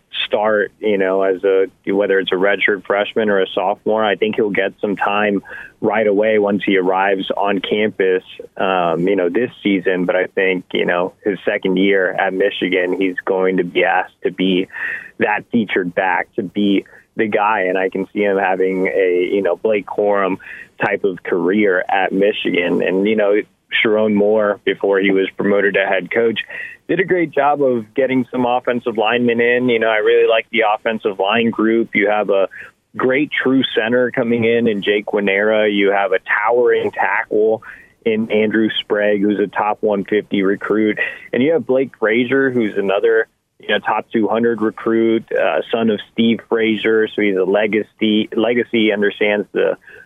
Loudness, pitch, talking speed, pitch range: -16 LUFS, 105 Hz, 180 wpm, 100-115 Hz